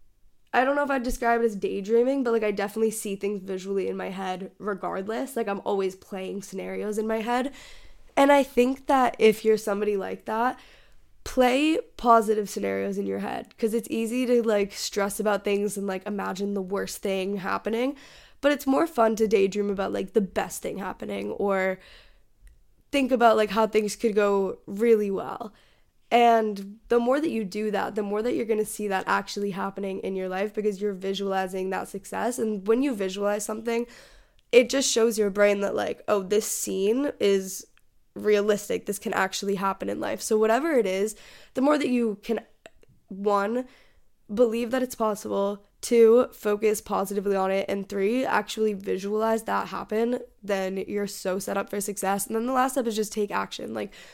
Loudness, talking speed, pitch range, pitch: -26 LUFS, 190 wpm, 200-230 Hz, 210 Hz